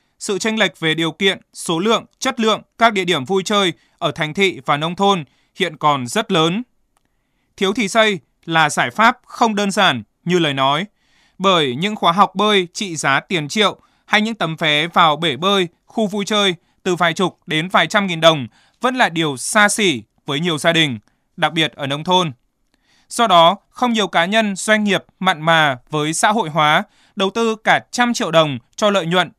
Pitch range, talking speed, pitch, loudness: 160-210 Hz, 205 wpm, 180 Hz, -17 LUFS